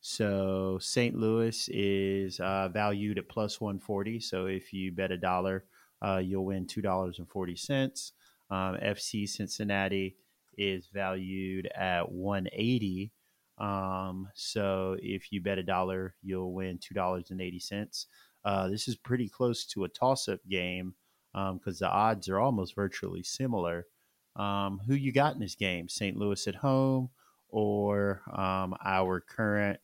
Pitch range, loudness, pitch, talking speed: 95-105 Hz, -33 LUFS, 95 Hz, 140 wpm